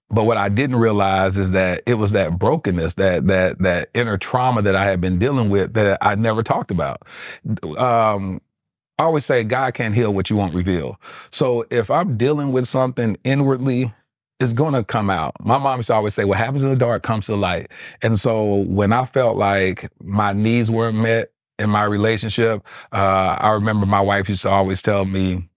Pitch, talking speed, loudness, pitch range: 105 Hz, 205 wpm, -18 LUFS, 95-120 Hz